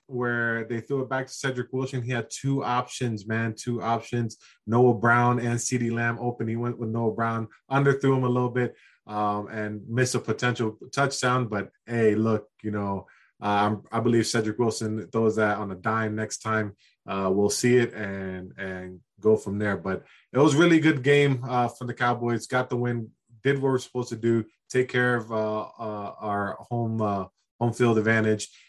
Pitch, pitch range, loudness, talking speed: 115 Hz, 110-125 Hz, -26 LUFS, 195 wpm